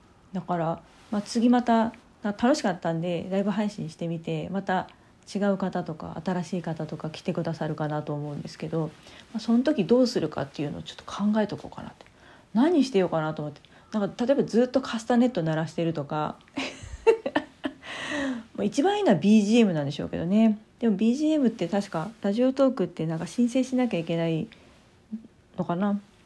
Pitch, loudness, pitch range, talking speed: 200 Hz, -26 LUFS, 165-235 Hz, 385 characters per minute